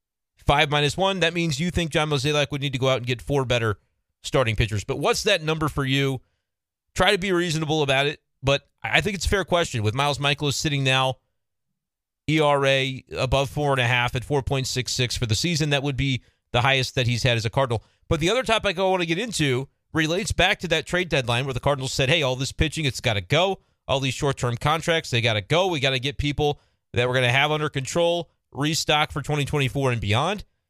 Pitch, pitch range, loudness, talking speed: 140 Hz, 130-155 Hz, -23 LUFS, 235 wpm